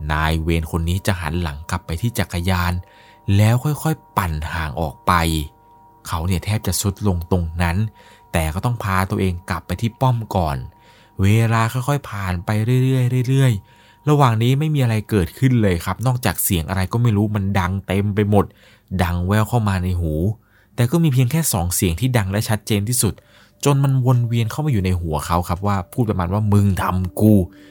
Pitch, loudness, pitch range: 100 Hz, -19 LUFS, 90-120 Hz